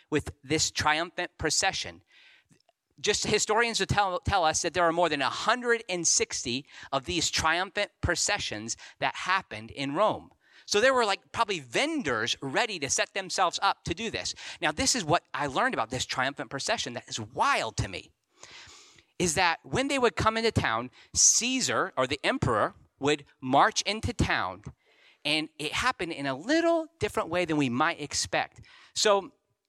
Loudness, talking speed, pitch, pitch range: -27 LUFS, 165 wpm, 165 Hz, 135-215 Hz